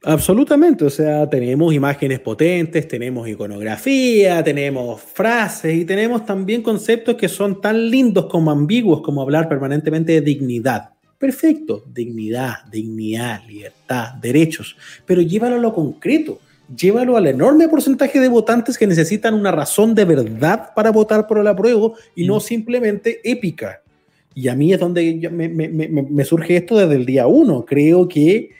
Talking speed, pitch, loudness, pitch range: 155 wpm, 170 Hz, -16 LUFS, 140-225 Hz